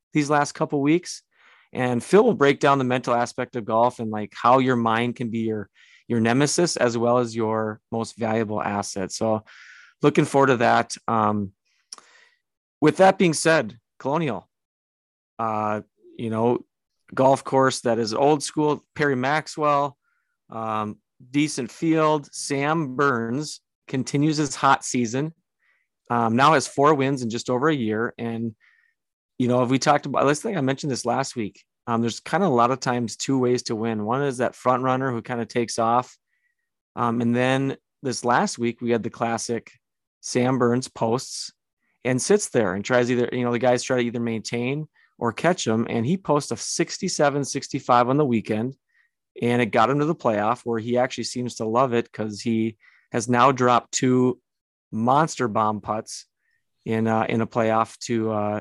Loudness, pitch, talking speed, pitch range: -23 LUFS, 125 Hz, 180 wpm, 115-140 Hz